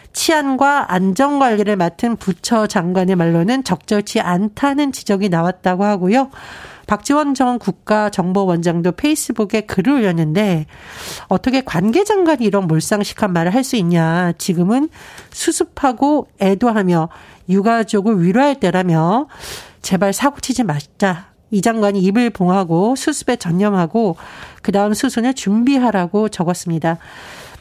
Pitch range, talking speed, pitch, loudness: 185-255 Hz, 300 characters per minute, 210 Hz, -16 LUFS